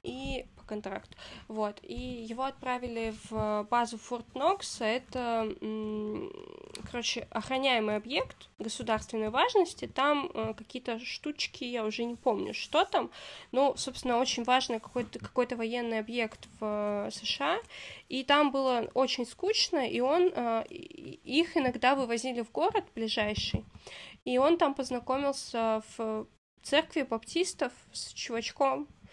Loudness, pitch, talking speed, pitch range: -31 LUFS, 245 Hz, 115 wpm, 225-280 Hz